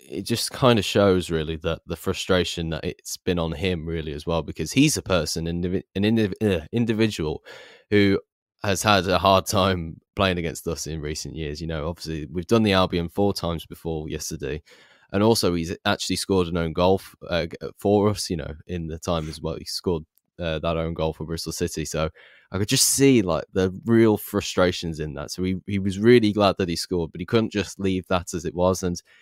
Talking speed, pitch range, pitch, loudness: 210 wpm, 80-100 Hz, 90 Hz, -23 LUFS